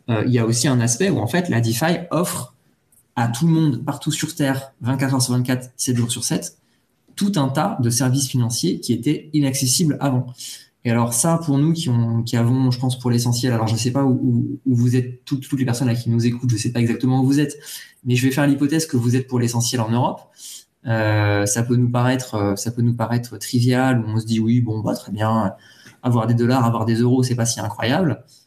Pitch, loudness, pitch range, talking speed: 125 Hz, -20 LUFS, 115-135 Hz, 250 wpm